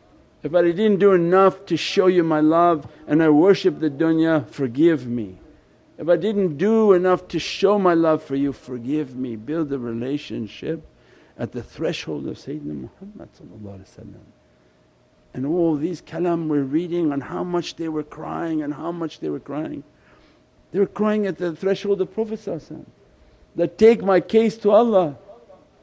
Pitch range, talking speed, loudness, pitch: 145-190 Hz, 165 wpm, -21 LUFS, 165 Hz